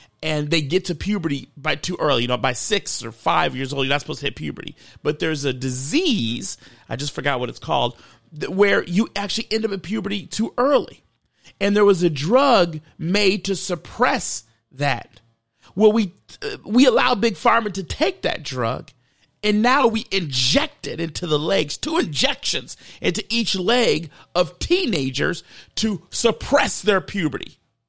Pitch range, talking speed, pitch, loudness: 140-210 Hz, 170 wpm, 180 Hz, -21 LUFS